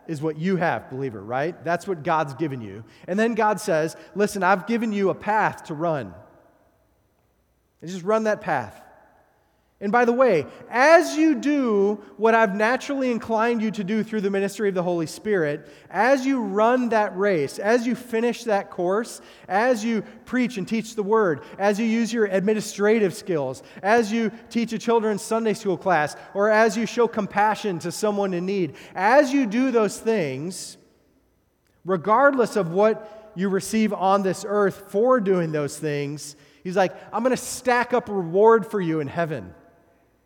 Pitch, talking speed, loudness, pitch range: 210 Hz, 175 wpm, -22 LUFS, 180-225 Hz